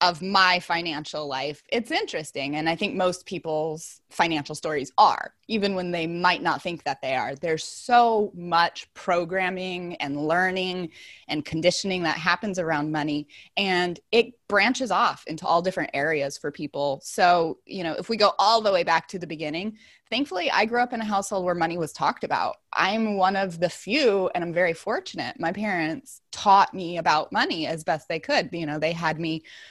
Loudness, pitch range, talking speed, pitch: -24 LUFS, 160-200 Hz, 190 wpm, 180 Hz